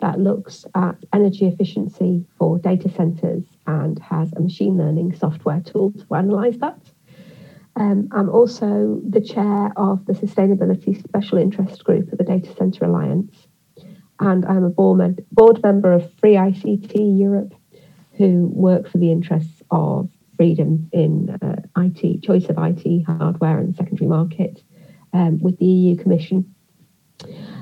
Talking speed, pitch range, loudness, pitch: 145 wpm, 170-195 Hz, -18 LUFS, 185 Hz